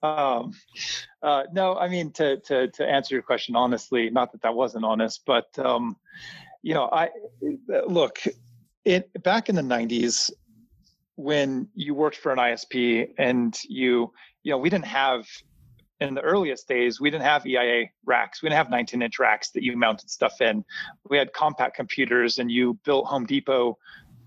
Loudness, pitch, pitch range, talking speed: -24 LUFS, 130 Hz, 120-155 Hz, 175 wpm